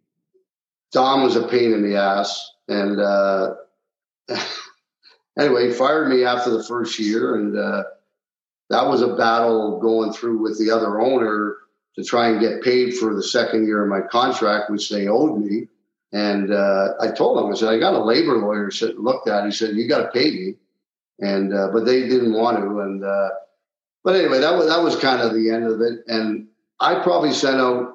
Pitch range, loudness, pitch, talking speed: 100-115 Hz, -19 LUFS, 110 Hz, 200 wpm